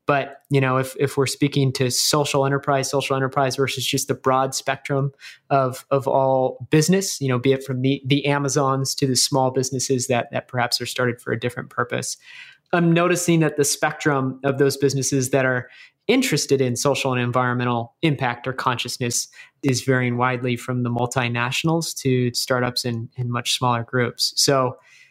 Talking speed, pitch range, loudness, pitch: 175 wpm, 125-140 Hz, -21 LUFS, 135 Hz